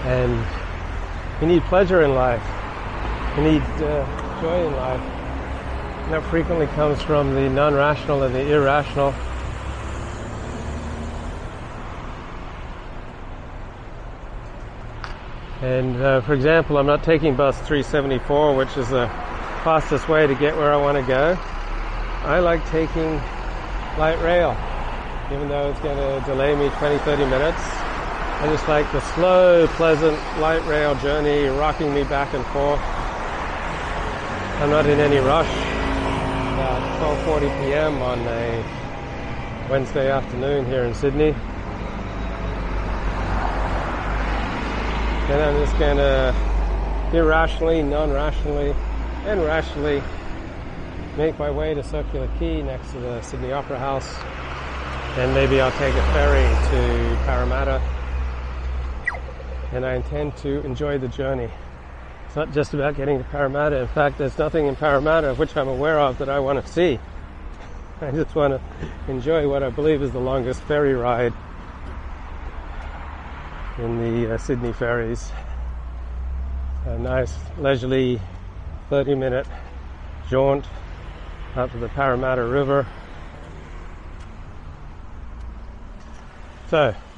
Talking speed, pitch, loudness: 120 wpm, 130 Hz, -22 LUFS